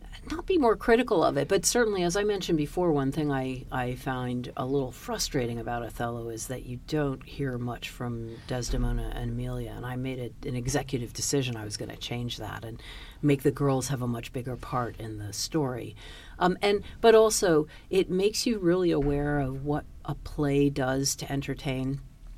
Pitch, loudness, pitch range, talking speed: 135 Hz, -28 LUFS, 120-150 Hz, 195 wpm